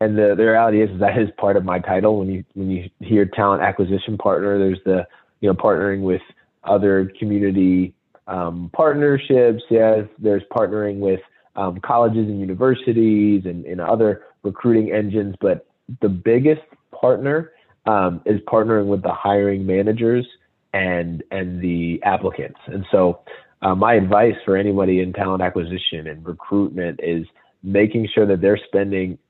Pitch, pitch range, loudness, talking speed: 100 Hz, 95-110 Hz, -19 LUFS, 155 wpm